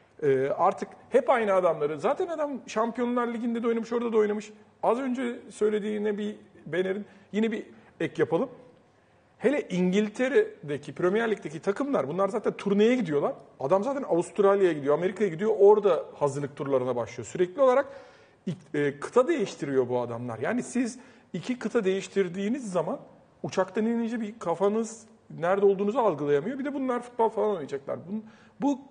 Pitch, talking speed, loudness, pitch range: 210 Hz, 140 wpm, -27 LUFS, 180-235 Hz